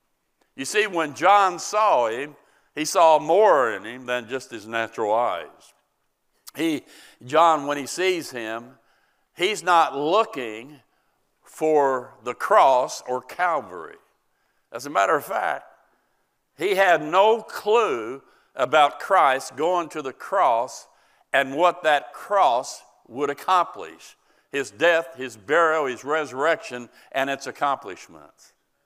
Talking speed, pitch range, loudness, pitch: 125 wpm, 130-195 Hz, -22 LUFS, 155 Hz